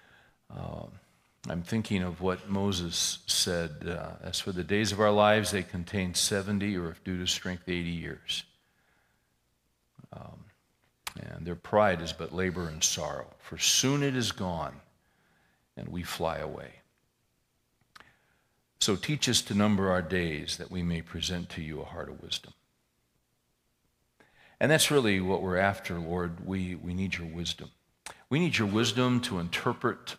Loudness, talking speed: -29 LUFS, 155 wpm